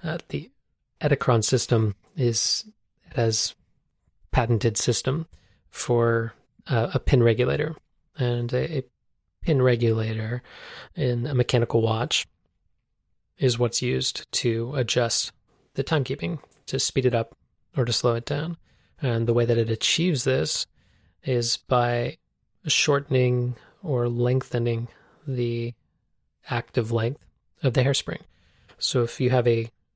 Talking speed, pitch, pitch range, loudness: 125 wpm, 120 Hz, 115-130 Hz, -25 LUFS